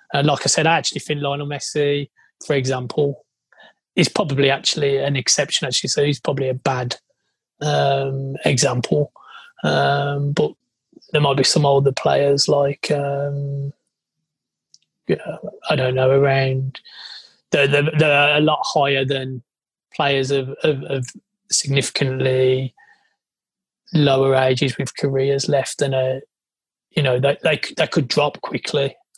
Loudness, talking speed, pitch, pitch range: -19 LUFS, 140 wpm, 140 Hz, 135-145 Hz